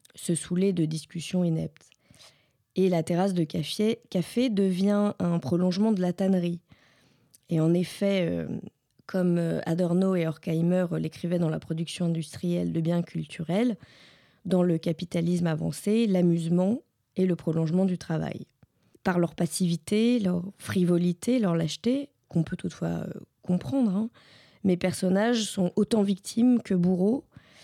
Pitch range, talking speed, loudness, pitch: 165-195 Hz, 135 wpm, -27 LUFS, 180 Hz